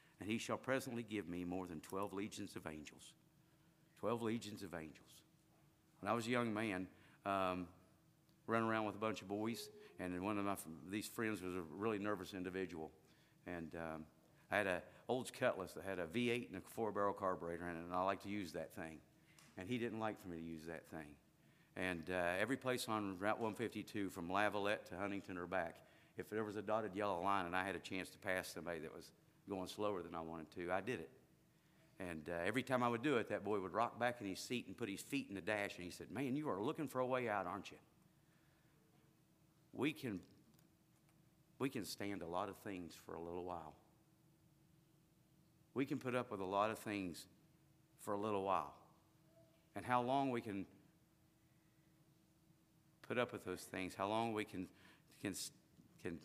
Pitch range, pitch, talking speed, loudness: 90-130 Hz, 105 Hz, 205 wpm, -44 LUFS